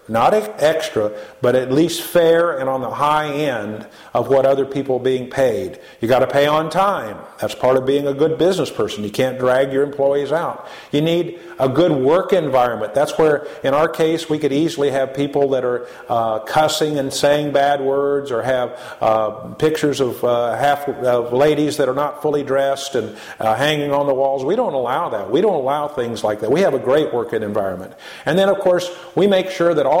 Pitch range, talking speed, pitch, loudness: 130-155 Hz, 215 wpm, 140 Hz, -18 LUFS